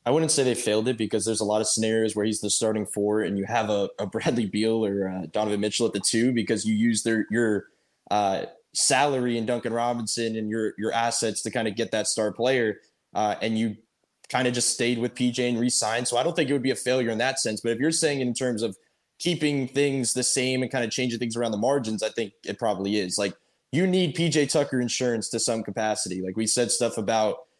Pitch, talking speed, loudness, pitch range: 115 Hz, 245 wpm, -25 LUFS, 110-125 Hz